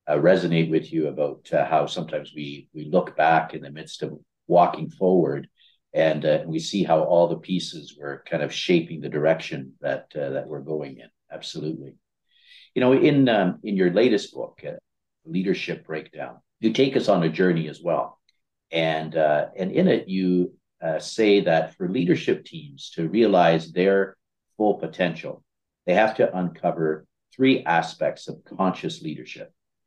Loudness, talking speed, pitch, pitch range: -23 LUFS, 170 wpm, 85 Hz, 80-110 Hz